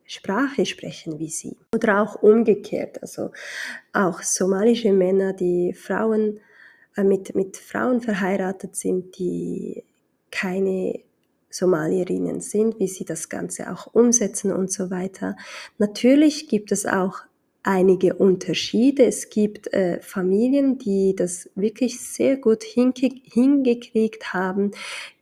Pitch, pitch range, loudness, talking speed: 200 Hz, 185-230 Hz, -22 LUFS, 120 wpm